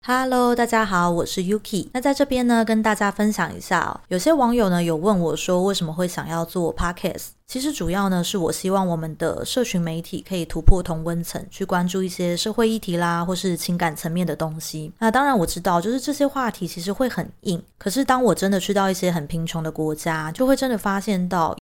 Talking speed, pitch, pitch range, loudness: 360 characters per minute, 185 Hz, 170-220 Hz, -22 LUFS